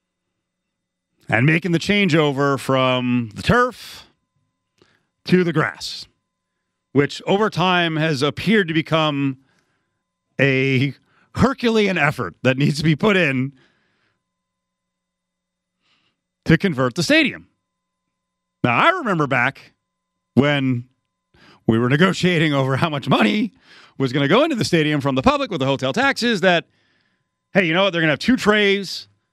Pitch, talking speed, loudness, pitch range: 145 Hz, 135 wpm, -18 LUFS, 125-180 Hz